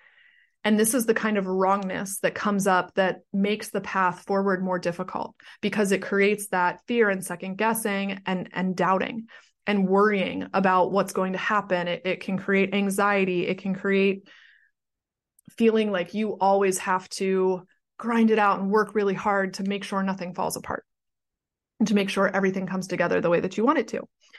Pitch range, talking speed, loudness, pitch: 185-210 Hz, 185 wpm, -25 LUFS, 195 Hz